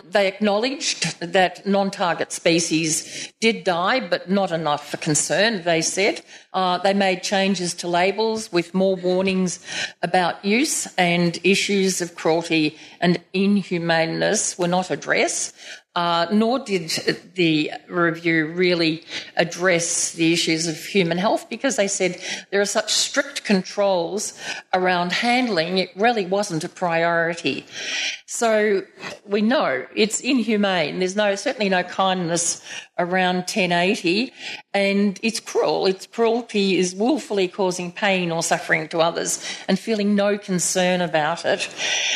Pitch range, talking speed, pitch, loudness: 170-205 Hz, 130 wpm, 185 Hz, -21 LUFS